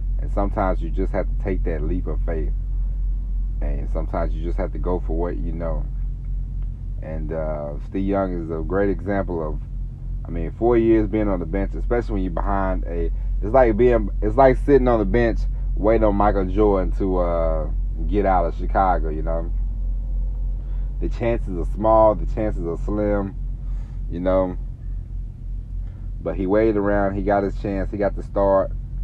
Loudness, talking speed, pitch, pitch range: -22 LUFS, 180 wpm, 100 Hz, 90-110 Hz